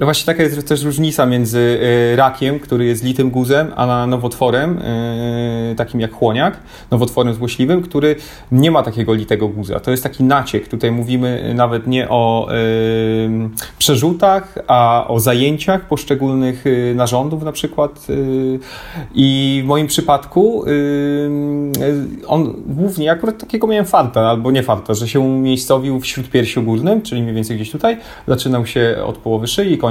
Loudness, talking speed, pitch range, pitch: -15 LUFS, 145 wpm, 120-145 Hz, 130 Hz